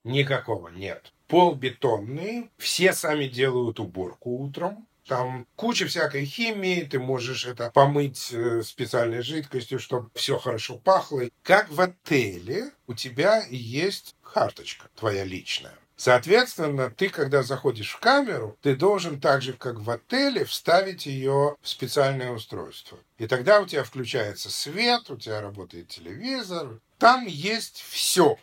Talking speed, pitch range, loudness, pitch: 130 wpm, 120-180 Hz, -25 LUFS, 135 Hz